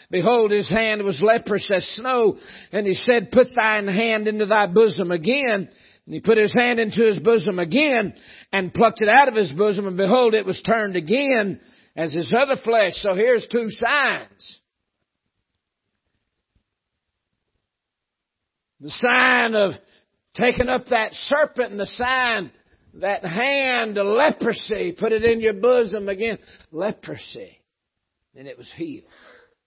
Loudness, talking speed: -19 LUFS, 145 wpm